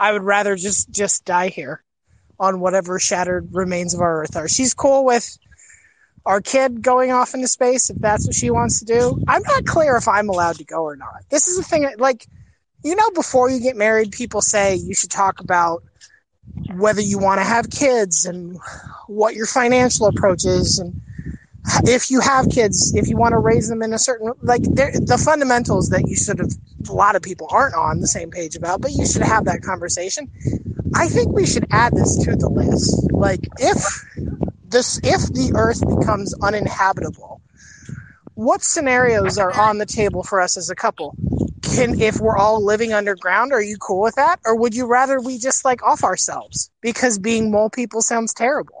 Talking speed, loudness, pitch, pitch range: 200 wpm, -18 LUFS, 220 Hz, 190-255 Hz